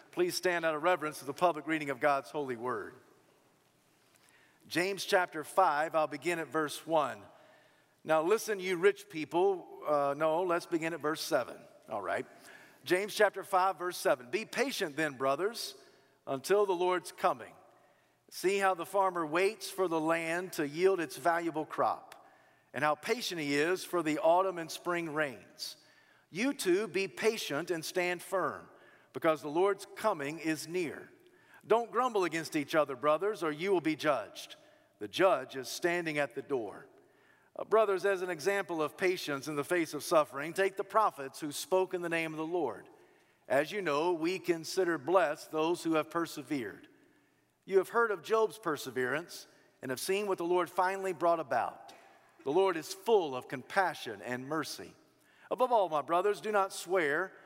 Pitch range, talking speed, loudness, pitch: 155-195 Hz, 175 wpm, -32 LUFS, 175 Hz